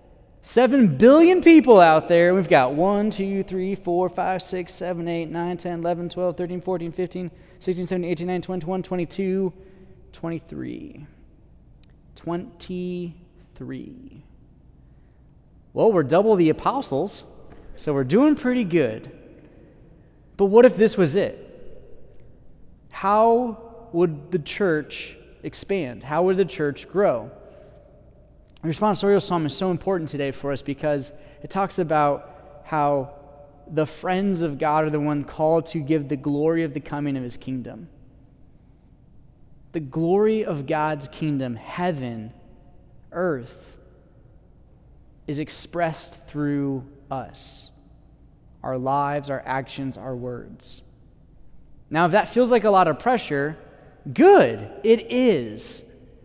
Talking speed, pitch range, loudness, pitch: 125 wpm, 145-185 Hz, -22 LUFS, 170 Hz